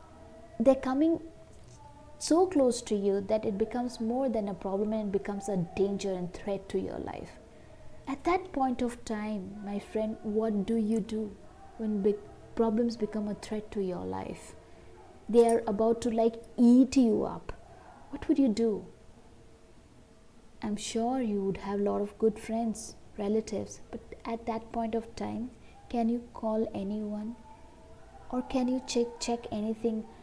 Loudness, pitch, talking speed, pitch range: -31 LUFS, 220 Hz, 160 wpm, 205-235 Hz